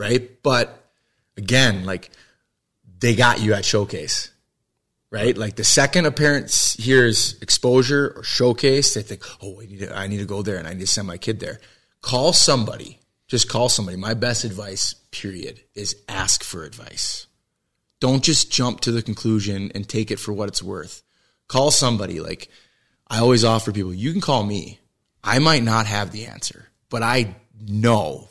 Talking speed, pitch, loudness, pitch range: 180 wpm, 115 Hz, -19 LUFS, 100-125 Hz